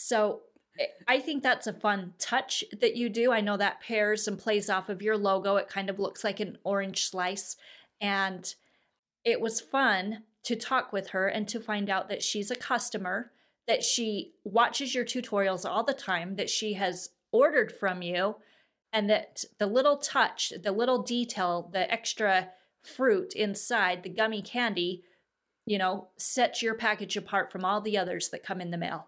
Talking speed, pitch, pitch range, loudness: 180 wpm, 210 Hz, 195-235 Hz, -29 LUFS